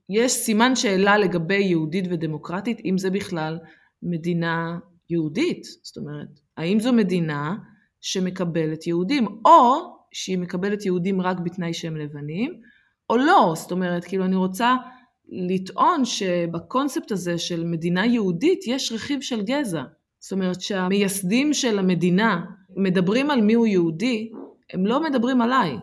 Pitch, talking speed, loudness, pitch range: 190 Hz, 130 wpm, -22 LUFS, 175-235 Hz